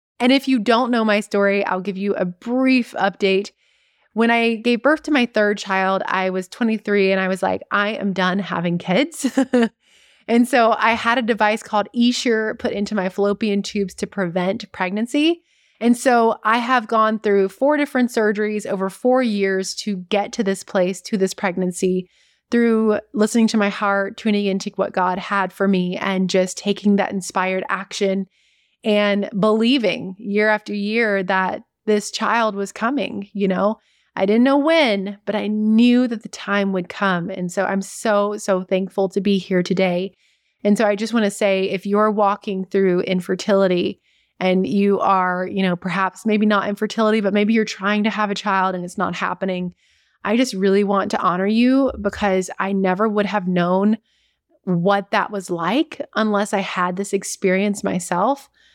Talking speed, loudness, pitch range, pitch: 180 wpm, -19 LUFS, 190-220 Hz, 205 Hz